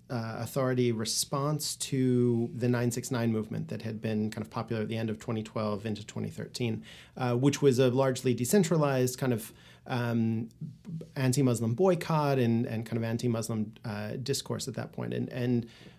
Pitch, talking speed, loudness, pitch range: 120 Hz, 160 wpm, -30 LUFS, 110-130 Hz